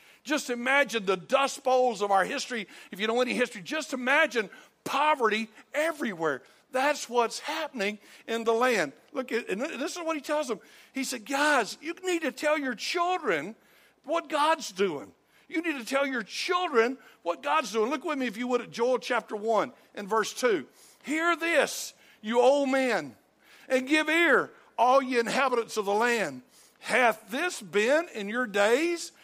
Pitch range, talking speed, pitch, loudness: 230-305 Hz, 175 wpm, 260 Hz, -27 LUFS